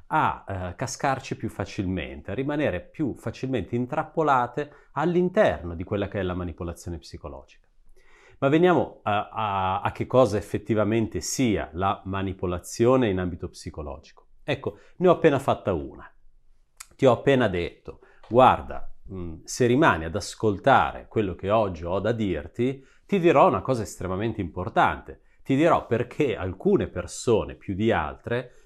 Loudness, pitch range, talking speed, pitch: -25 LUFS, 90-130 Hz, 140 wpm, 105 Hz